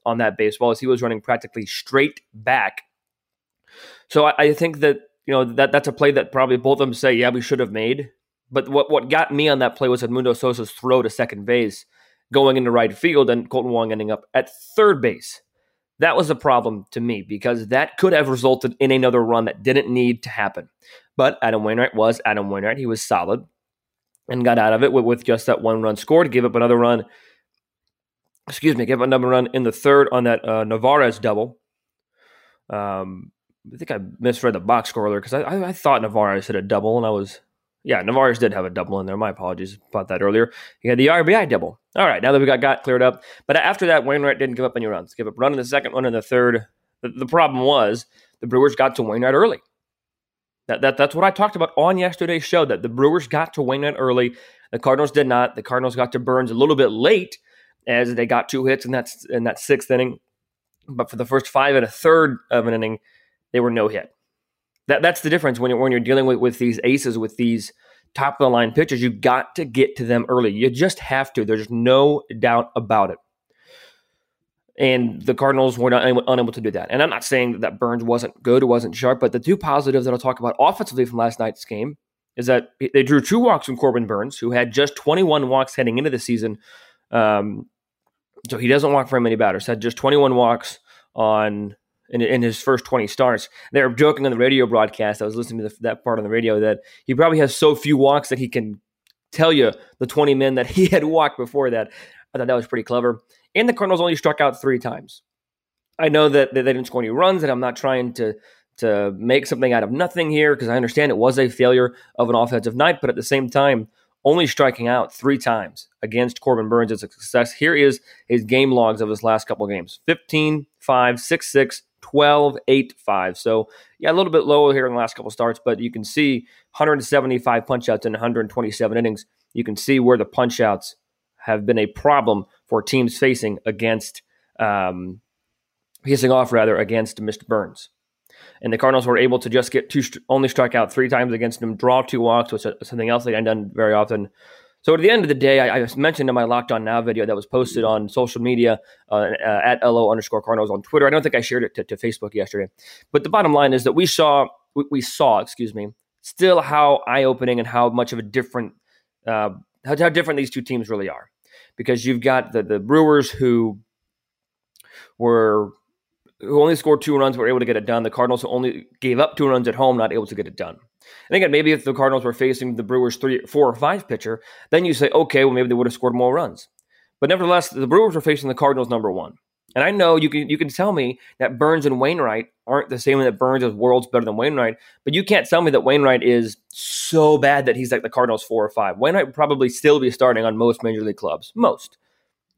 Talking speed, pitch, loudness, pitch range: 230 wpm, 125 Hz, -19 LUFS, 115-140 Hz